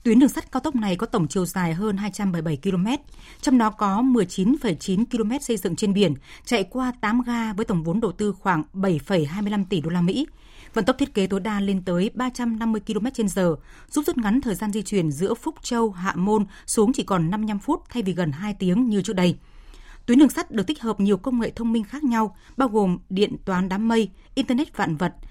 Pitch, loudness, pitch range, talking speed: 215 Hz, -23 LUFS, 190-240 Hz, 225 wpm